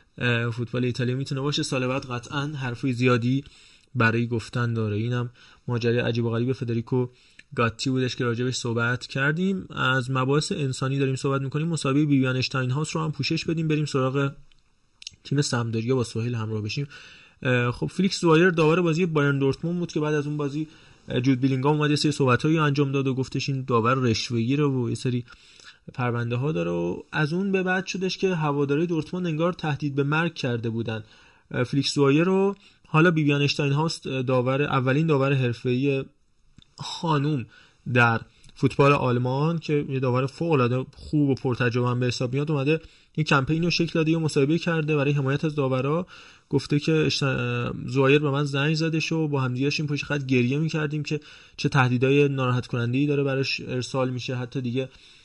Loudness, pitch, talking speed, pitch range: -24 LUFS, 140 Hz, 170 wpm, 125-150 Hz